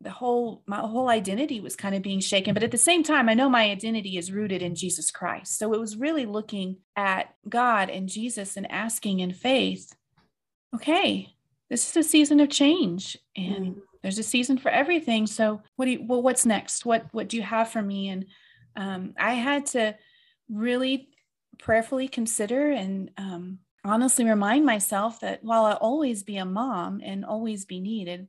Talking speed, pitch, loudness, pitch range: 185 wpm, 220 Hz, -25 LUFS, 195-250 Hz